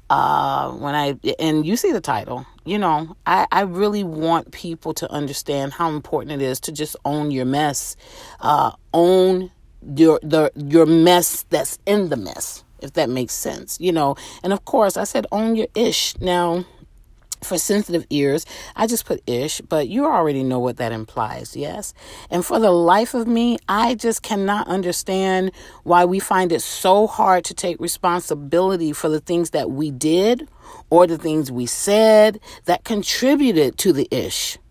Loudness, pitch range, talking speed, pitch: -19 LUFS, 155-200 Hz, 175 wpm, 175 Hz